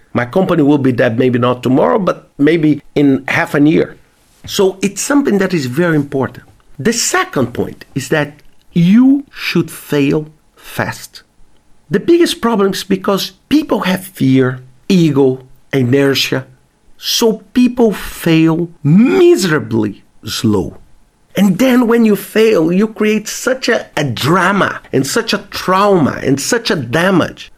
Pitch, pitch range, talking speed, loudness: 170 Hz, 135-215 Hz, 140 wpm, -13 LUFS